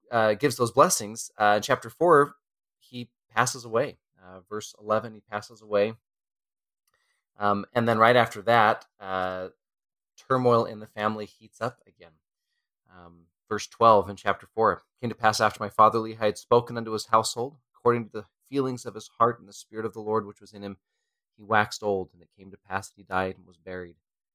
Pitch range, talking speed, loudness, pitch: 100-120 Hz, 195 wpm, -25 LUFS, 110 Hz